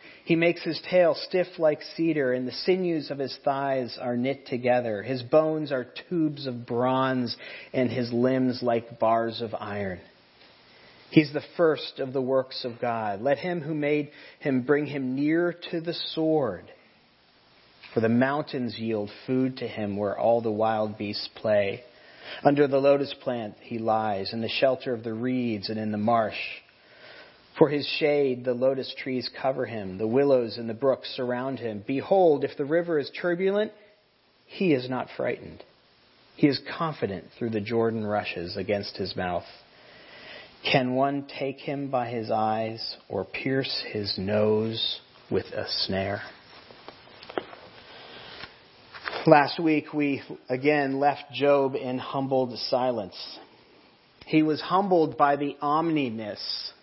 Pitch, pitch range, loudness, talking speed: 130 Hz, 115-145 Hz, -27 LUFS, 150 wpm